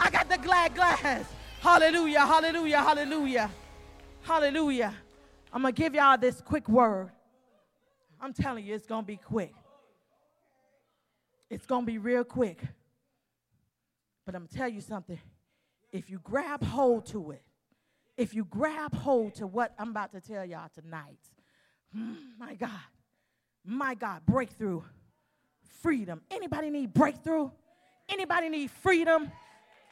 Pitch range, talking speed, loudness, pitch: 210-305 Hz, 135 wpm, -28 LUFS, 245 Hz